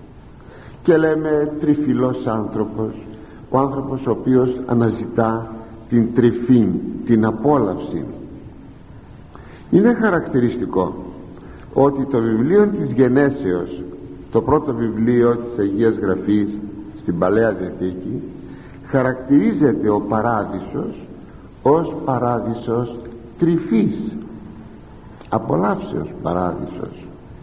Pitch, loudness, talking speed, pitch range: 115 Hz, -19 LUFS, 80 wpm, 110-130 Hz